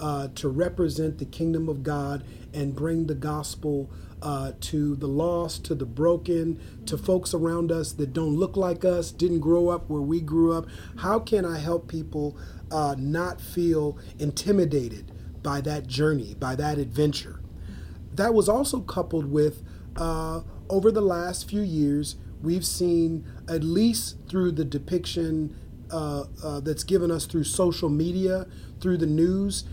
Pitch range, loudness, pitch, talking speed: 145-175 Hz, -26 LUFS, 160 Hz, 155 wpm